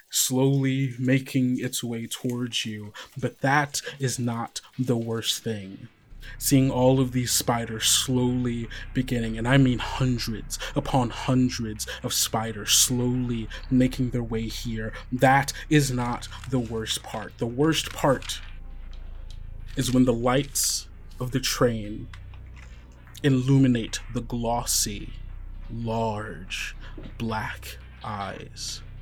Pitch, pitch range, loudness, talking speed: 120 Hz, 110-130 Hz, -25 LUFS, 115 wpm